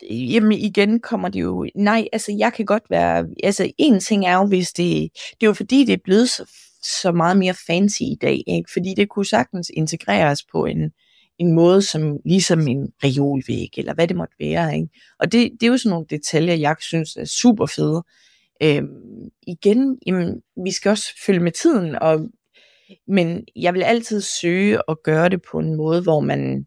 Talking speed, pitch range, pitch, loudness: 200 wpm, 160-215 Hz, 185 Hz, -19 LUFS